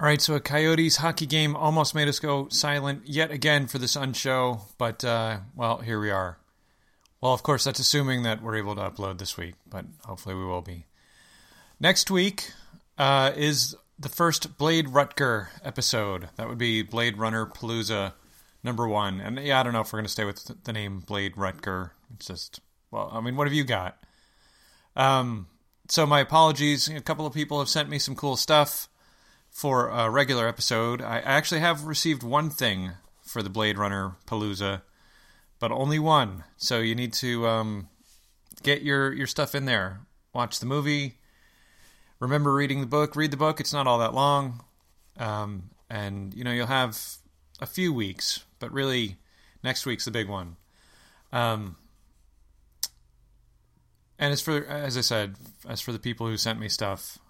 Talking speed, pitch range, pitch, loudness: 180 wpm, 100-145 Hz, 120 Hz, -26 LUFS